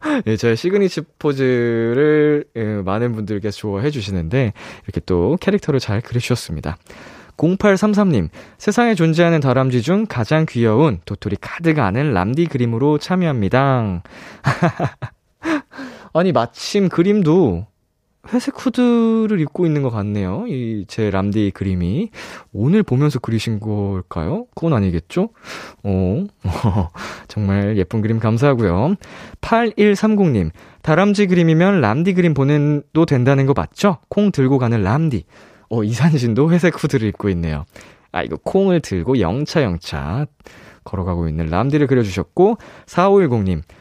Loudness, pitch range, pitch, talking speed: -18 LUFS, 105-170 Hz, 130 Hz, 275 characters per minute